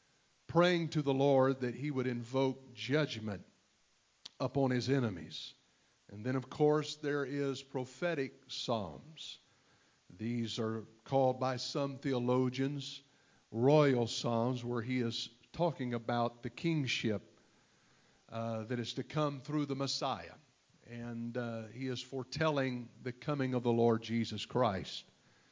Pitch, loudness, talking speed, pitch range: 130 Hz, -35 LUFS, 130 wpm, 115-140 Hz